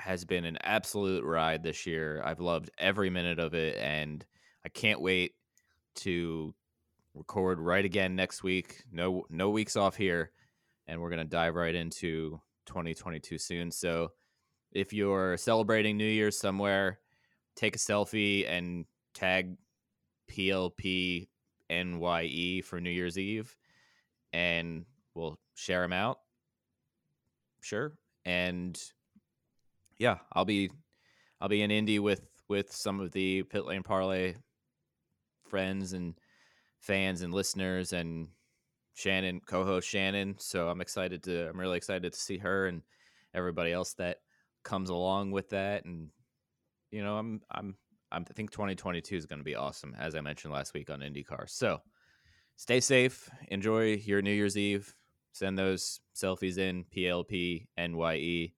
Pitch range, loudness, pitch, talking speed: 85-100 Hz, -33 LUFS, 95 Hz, 145 wpm